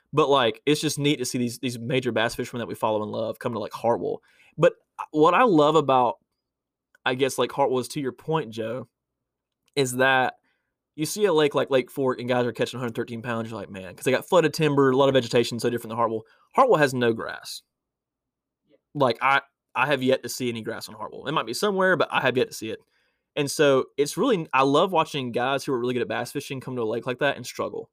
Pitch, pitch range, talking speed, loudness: 130 Hz, 120-145 Hz, 245 wpm, -24 LUFS